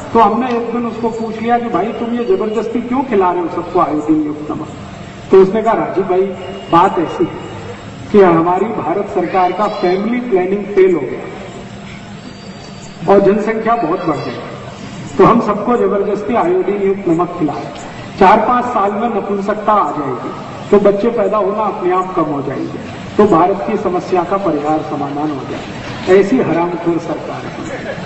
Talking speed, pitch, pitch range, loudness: 175 wpm, 200 Hz, 180-225 Hz, -14 LUFS